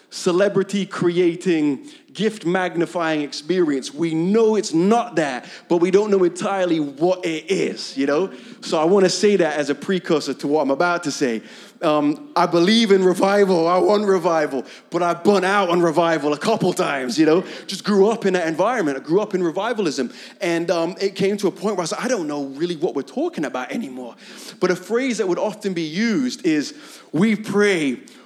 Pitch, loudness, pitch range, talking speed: 180 Hz, -20 LUFS, 165-205 Hz, 200 wpm